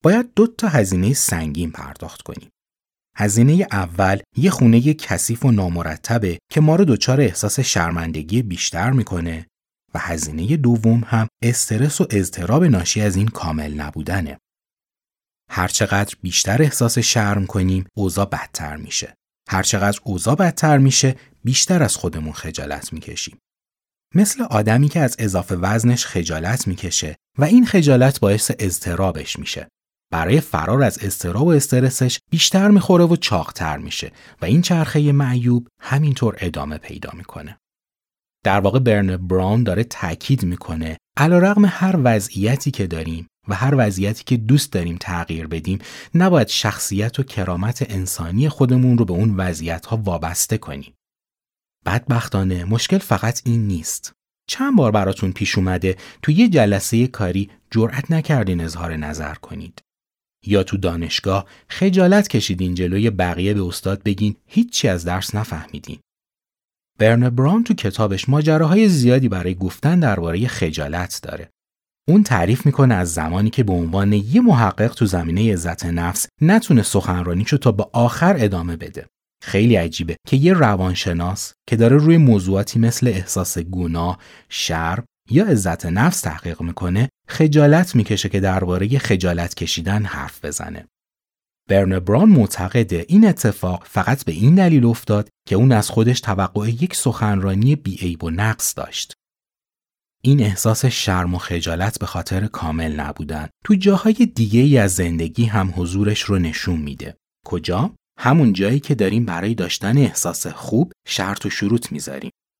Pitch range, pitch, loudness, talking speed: 90-130 Hz, 105 Hz, -18 LUFS, 140 wpm